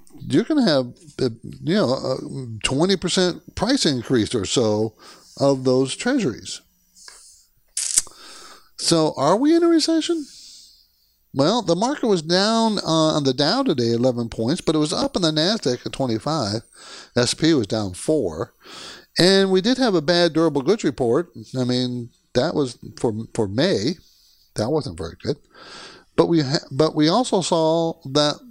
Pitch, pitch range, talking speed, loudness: 155 Hz, 125-185 Hz, 155 wpm, -20 LUFS